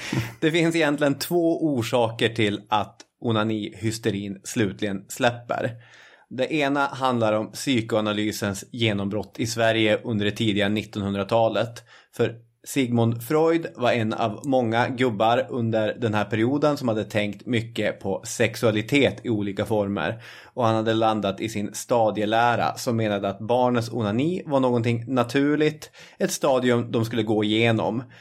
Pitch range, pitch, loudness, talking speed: 105-125 Hz, 115 Hz, -24 LUFS, 135 wpm